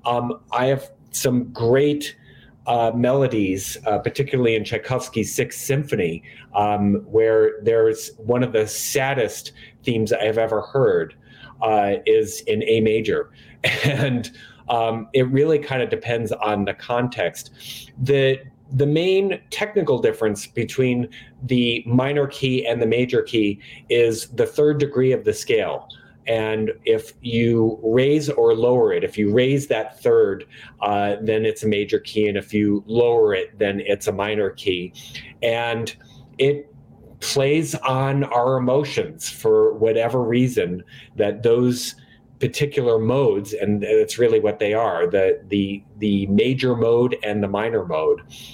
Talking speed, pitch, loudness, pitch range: 140 wpm, 125 Hz, -20 LUFS, 115-145 Hz